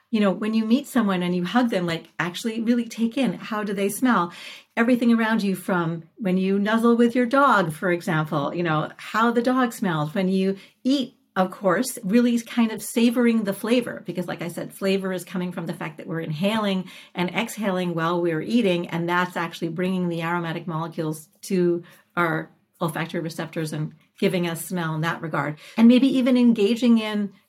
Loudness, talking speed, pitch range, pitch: -23 LUFS, 195 wpm, 175-230 Hz, 190 Hz